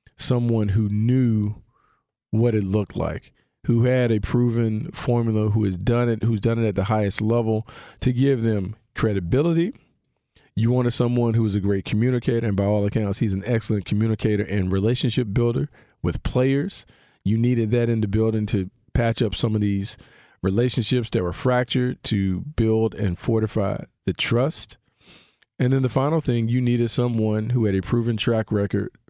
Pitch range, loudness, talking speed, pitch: 105-120 Hz, -22 LUFS, 175 wpm, 115 Hz